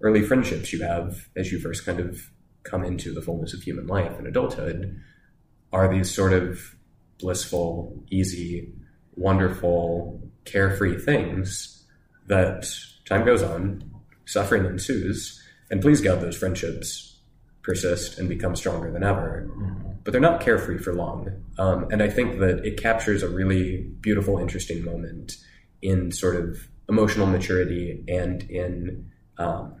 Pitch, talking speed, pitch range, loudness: 90 Hz, 140 wpm, 85-95 Hz, -25 LUFS